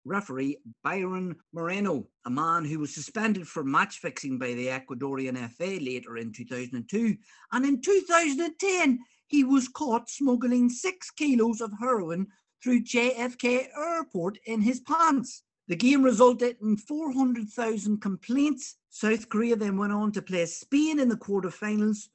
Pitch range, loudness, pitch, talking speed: 180-255 Hz, -27 LUFS, 220 Hz, 140 wpm